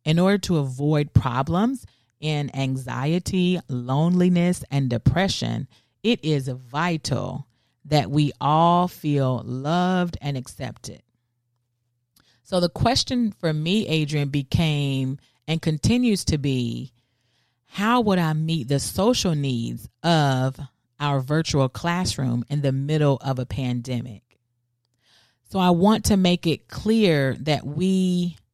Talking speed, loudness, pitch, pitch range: 120 wpm, -23 LUFS, 145 Hz, 125-175 Hz